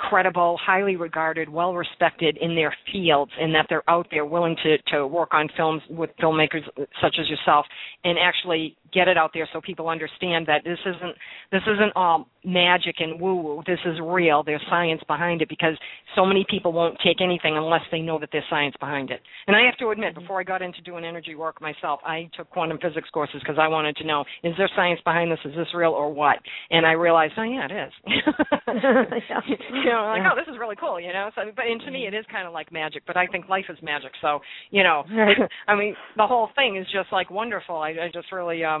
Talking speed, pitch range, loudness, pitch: 230 wpm, 155-190 Hz, -23 LUFS, 170 Hz